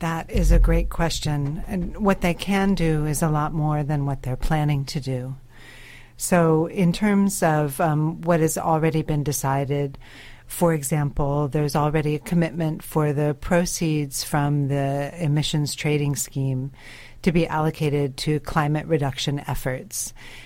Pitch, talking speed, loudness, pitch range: 150 Hz, 150 wpm, -23 LUFS, 140-165 Hz